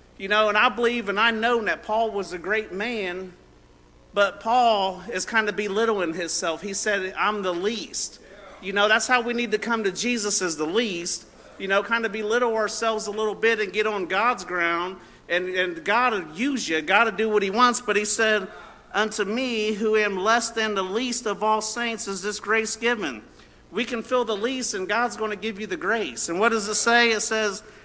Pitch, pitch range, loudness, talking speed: 215 Hz, 195-230 Hz, -23 LUFS, 220 wpm